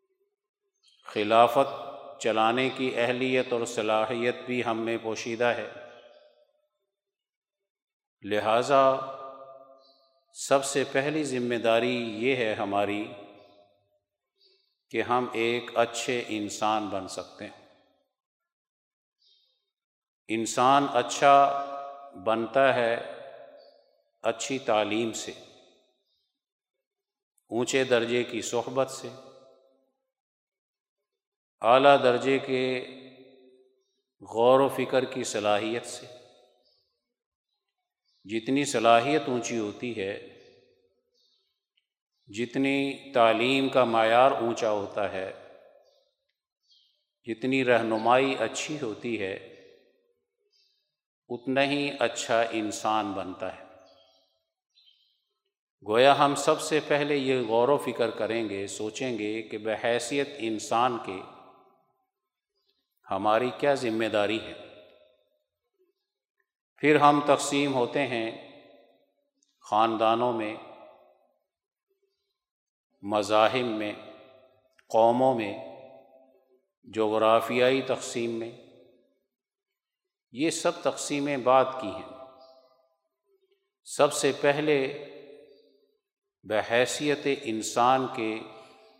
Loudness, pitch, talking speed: -26 LUFS, 130 Hz, 80 wpm